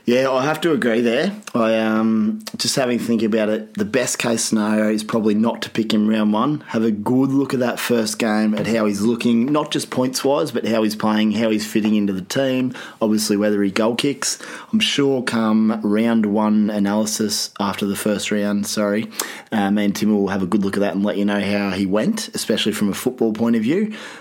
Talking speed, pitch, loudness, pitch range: 230 wpm, 110 Hz, -19 LUFS, 105-120 Hz